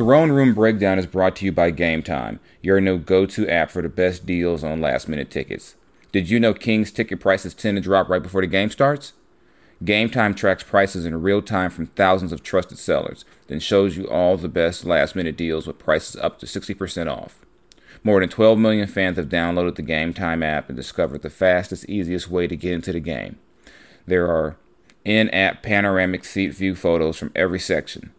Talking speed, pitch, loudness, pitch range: 190 wpm, 95 Hz, -21 LUFS, 85-100 Hz